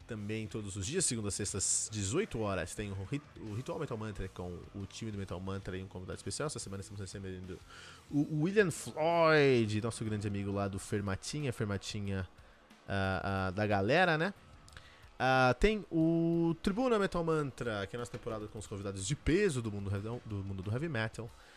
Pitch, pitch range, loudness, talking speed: 105 Hz, 95-125 Hz, -34 LUFS, 180 wpm